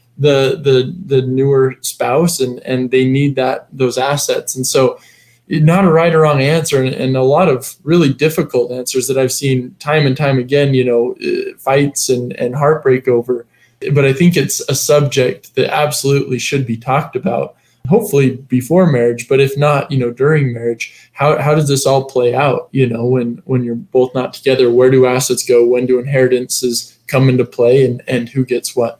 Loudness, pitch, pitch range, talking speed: -14 LUFS, 130 Hz, 125-145 Hz, 195 wpm